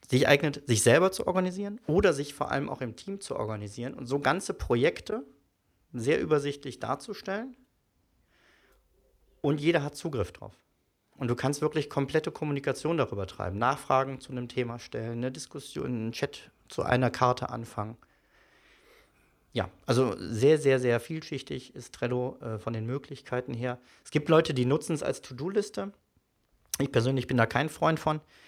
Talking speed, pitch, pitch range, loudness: 160 wpm, 135 Hz, 120-155 Hz, -29 LUFS